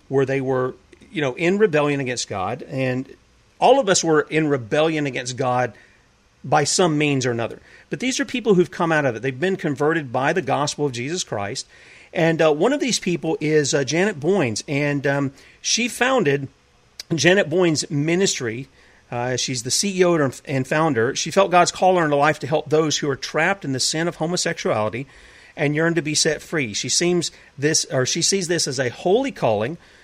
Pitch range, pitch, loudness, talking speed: 135-175 Hz, 150 Hz, -20 LUFS, 200 wpm